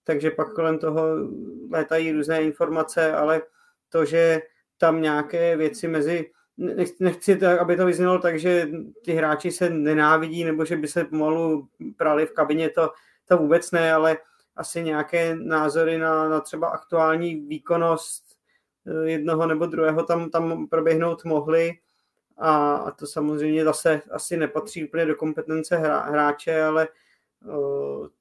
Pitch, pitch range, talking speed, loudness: 160 Hz, 155-170 Hz, 140 wpm, -23 LUFS